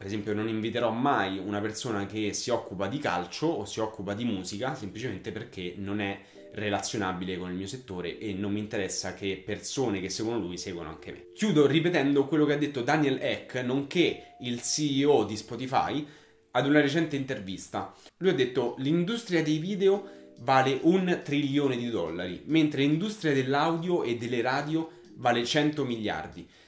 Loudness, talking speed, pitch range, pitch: -29 LUFS, 170 wpm, 105-150 Hz, 130 Hz